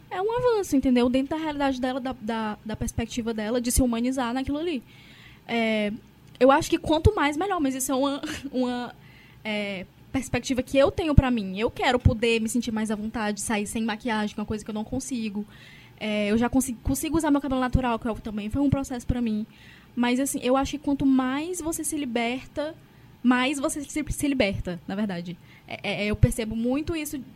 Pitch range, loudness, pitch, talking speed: 220-280 Hz, -26 LUFS, 250 Hz, 210 wpm